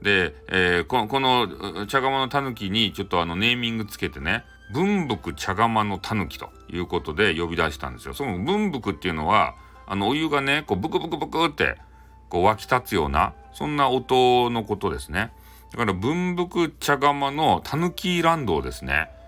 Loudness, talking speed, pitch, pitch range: -23 LUFS, 360 characters per minute, 115 Hz, 90-145 Hz